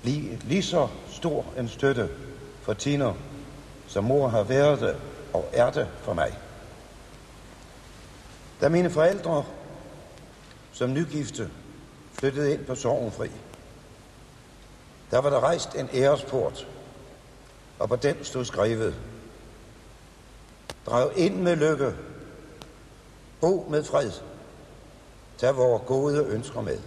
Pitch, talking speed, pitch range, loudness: 135 Hz, 110 wpm, 125-145 Hz, -26 LUFS